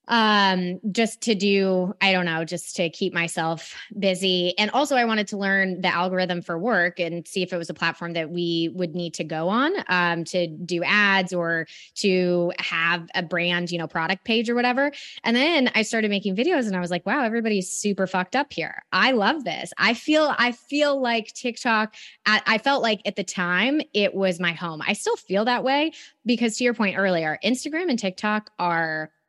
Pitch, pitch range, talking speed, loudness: 195 Hz, 175-230 Hz, 205 wpm, -23 LUFS